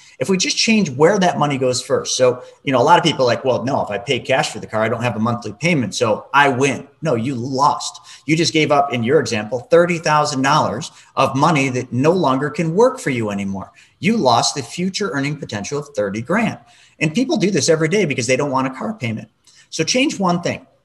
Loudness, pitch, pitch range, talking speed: -17 LUFS, 145 Hz, 125-175 Hz, 240 wpm